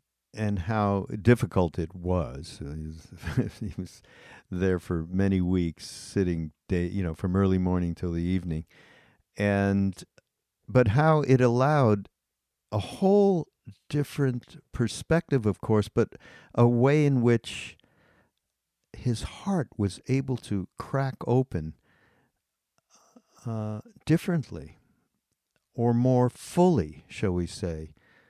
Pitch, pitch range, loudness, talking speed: 105 Hz, 90-130 Hz, -27 LUFS, 110 wpm